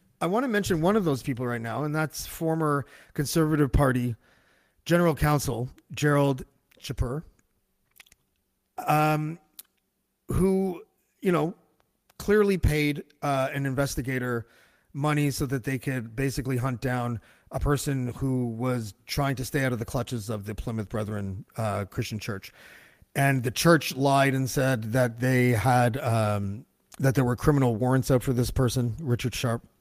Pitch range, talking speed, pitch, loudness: 120-150 Hz, 150 wpm, 135 Hz, -27 LUFS